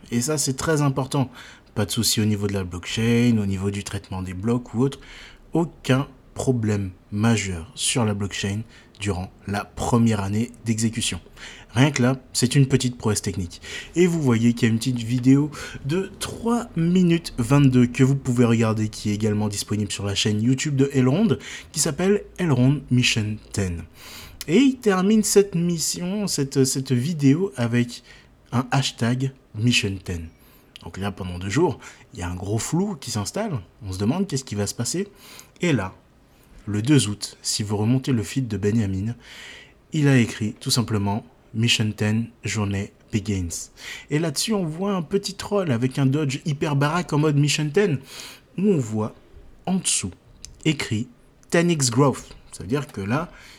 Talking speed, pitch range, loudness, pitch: 175 wpm, 105-140 Hz, -23 LUFS, 120 Hz